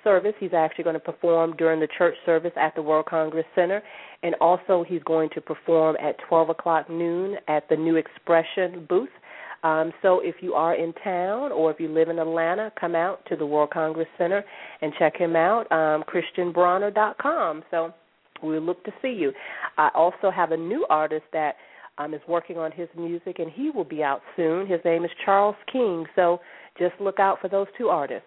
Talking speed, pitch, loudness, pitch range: 200 wpm, 170 Hz, -24 LUFS, 160-185 Hz